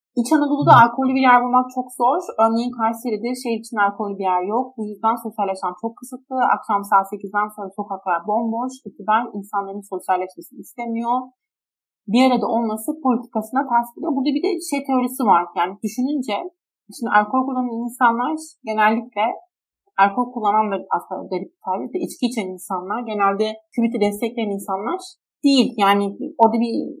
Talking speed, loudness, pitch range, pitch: 150 wpm, -20 LUFS, 205-255 Hz, 230 Hz